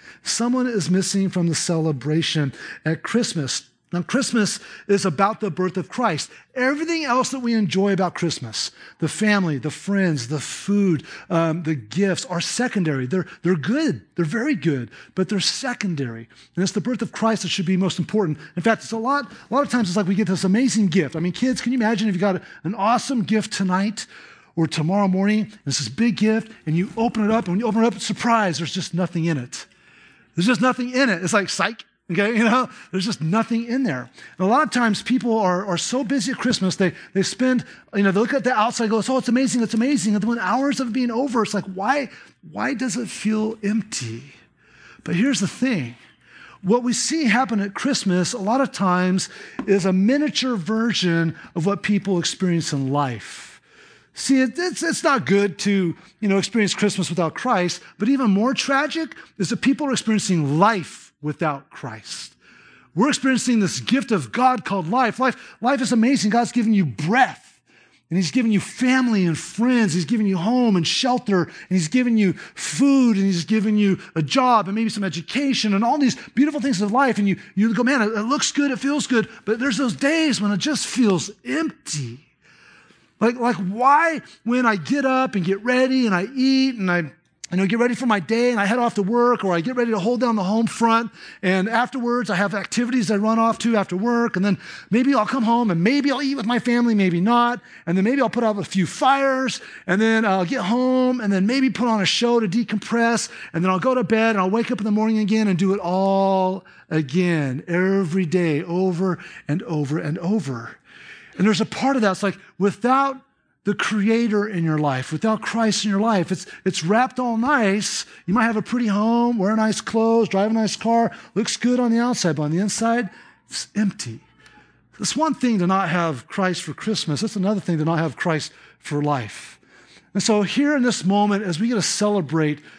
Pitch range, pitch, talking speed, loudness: 185-240 Hz, 210 Hz, 215 wpm, -21 LUFS